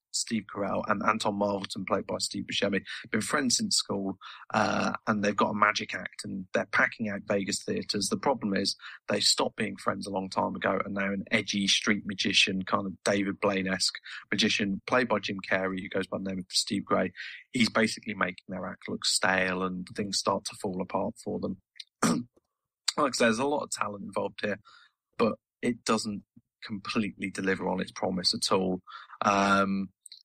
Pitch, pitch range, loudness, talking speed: 95 Hz, 95-100 Hz, -29 LUFS, 190 wpm